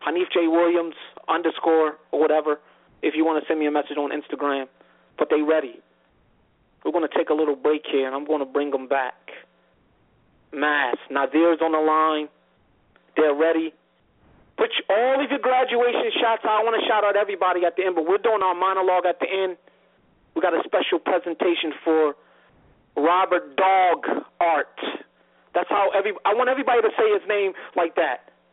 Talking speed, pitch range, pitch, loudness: 185 wpm, 150-195 Hz, 165 Hz, -22 LUFS